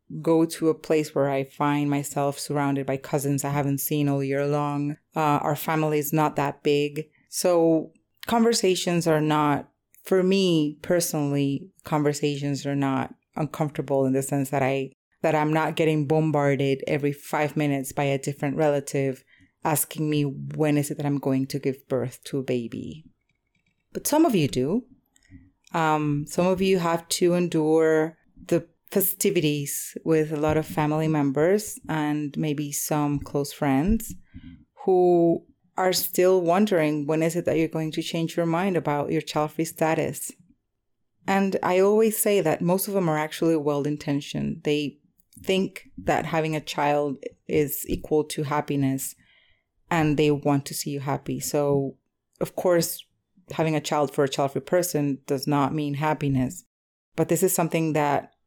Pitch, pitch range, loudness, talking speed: 150 Hz, 140-165 Hz, -24 LUFS, 160 wpm